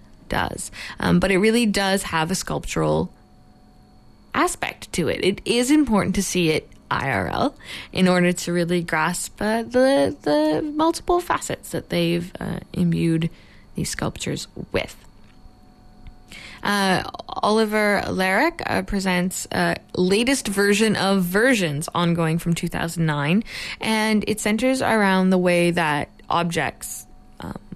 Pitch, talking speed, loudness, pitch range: 185 Hz, 130 wpm, -21 LUFS, 170-215 Hz